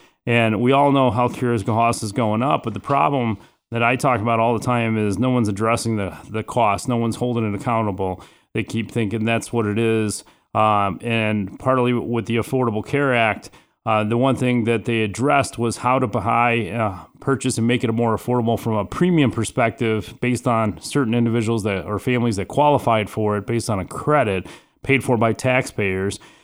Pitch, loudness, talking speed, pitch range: 115 Hz, -20 LUFS, 200 wpm, 110-125 Hz